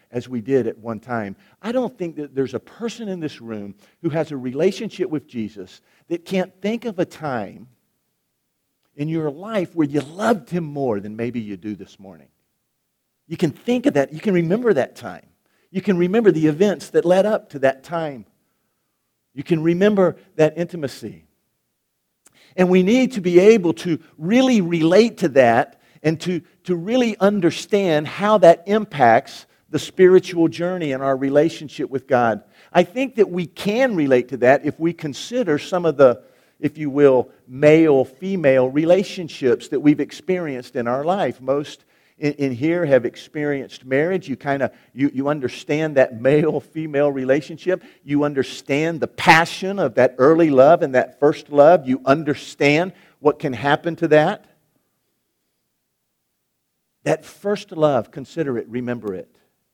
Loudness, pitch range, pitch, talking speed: -19 LUFS, 135-180 Hz, 155 Hz, 165 wpm